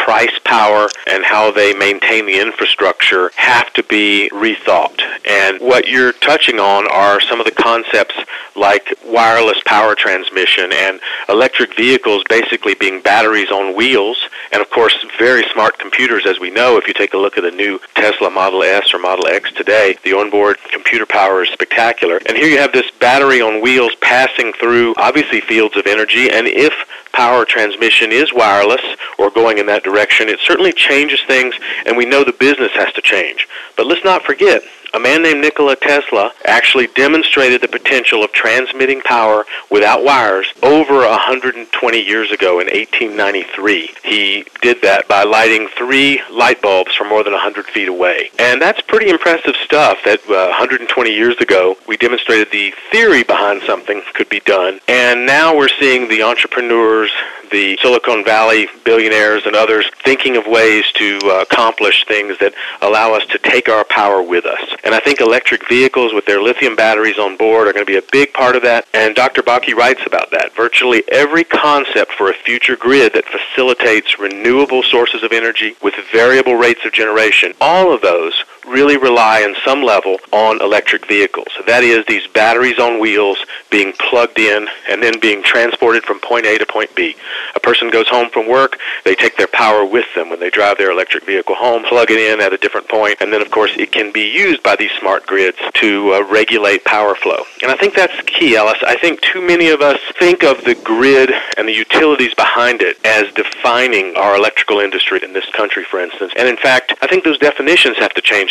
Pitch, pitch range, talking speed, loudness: 115 Hz, 105-135 Hz, 190 wpm, -11 LUFS